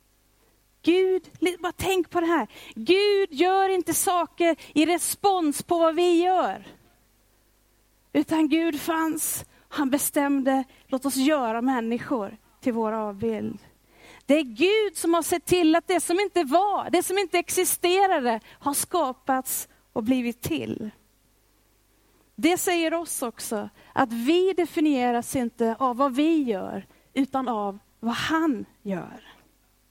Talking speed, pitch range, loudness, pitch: 130 wpm, 260-350 Hz, -24 LUFS, 315 Hz